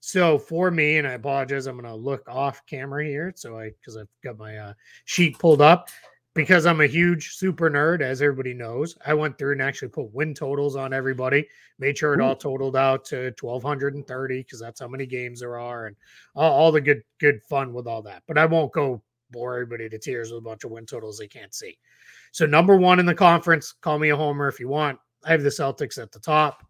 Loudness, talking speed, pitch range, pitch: -22 LUFS, 235 wpm, 125-155 Hz, 140 Hz